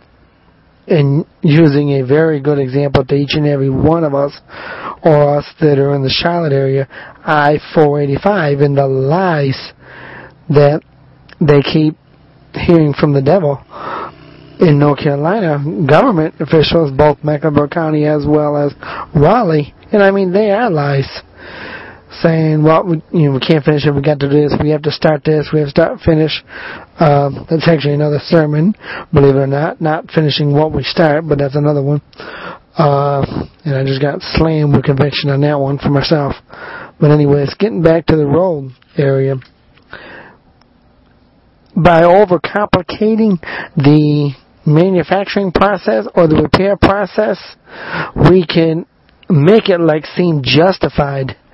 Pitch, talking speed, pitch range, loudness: 150 Hz, 155 wpm, 140-165 Hz, -12 LUFS